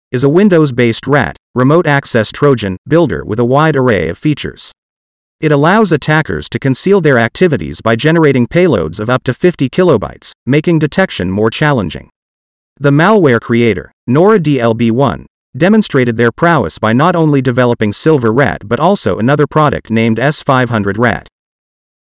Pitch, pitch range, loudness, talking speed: 135 Hz, 115-155 Hz, -11 LUFS, 150 wpm